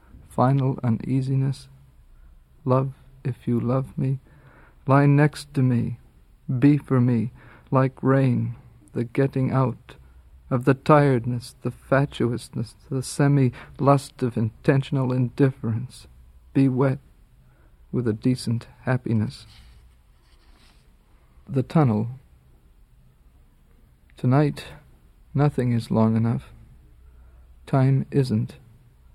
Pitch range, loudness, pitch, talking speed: 110-135 Hz, -23 LUFS, 125 Hz, 95 wpm